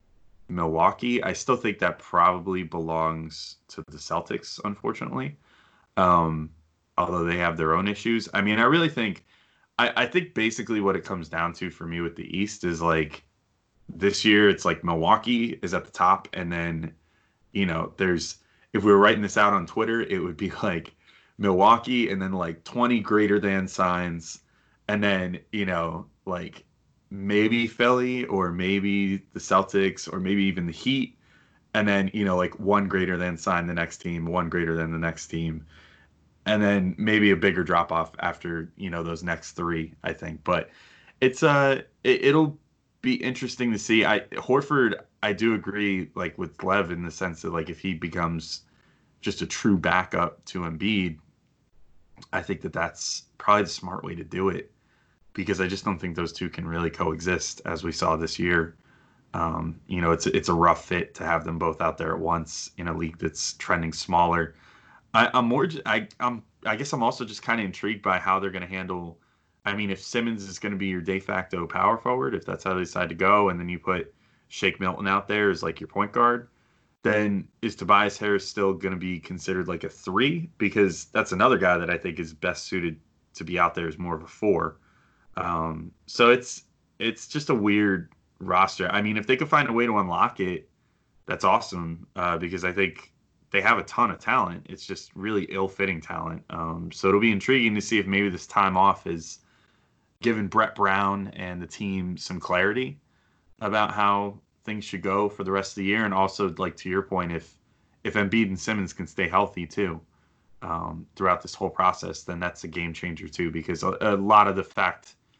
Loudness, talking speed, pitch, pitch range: -25 LUFS, 200 wpm, 95 Hz, 85-105 Hz